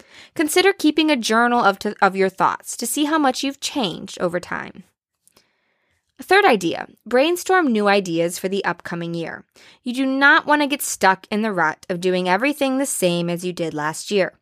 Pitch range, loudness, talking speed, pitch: 185-285 Hz, -19 LUFS, 195 wpm, 220 Hz